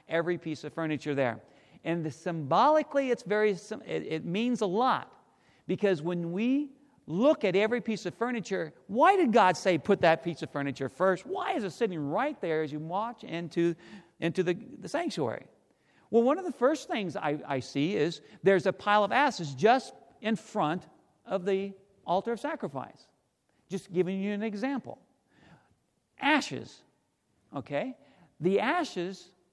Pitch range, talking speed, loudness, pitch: 170-235 Hz, 165 wpm, -29 LUFS, 195 Hz